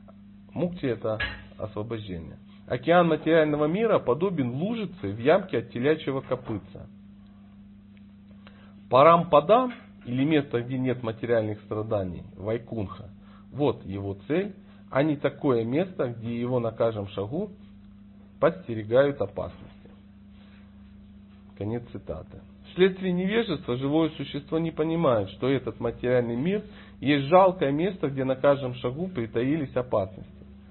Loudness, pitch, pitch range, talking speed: -26 LUFS, 115 Hz, 100-145 Hz, 110 wpm